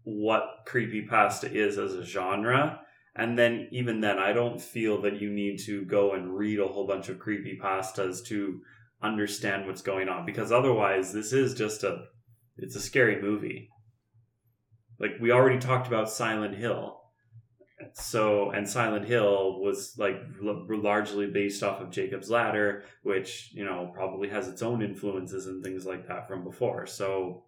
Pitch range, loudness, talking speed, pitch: 95-115 Hz, -29 LUFS, 170 wpm, 105 Hz